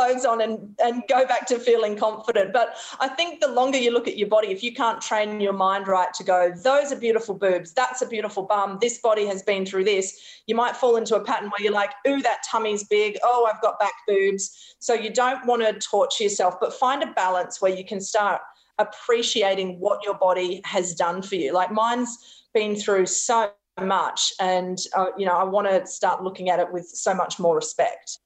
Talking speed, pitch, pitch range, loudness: 225 wpm, 210 Hz, 195-240 Hz, -23 LUFS